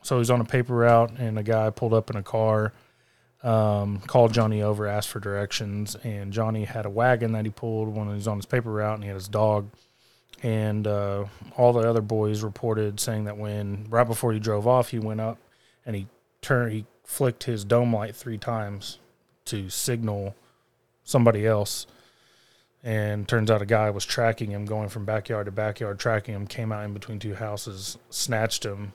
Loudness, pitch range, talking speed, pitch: -26 LUFS, 105-115 Hz, 205 wpm, 110 Hz